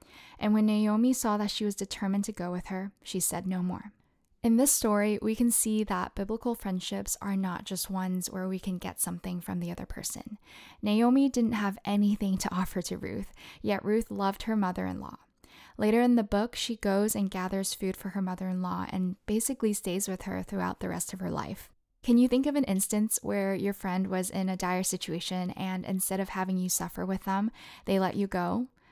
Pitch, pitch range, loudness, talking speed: 195 Hz, 185-215 Hz, -30 LUFS, 215 wpm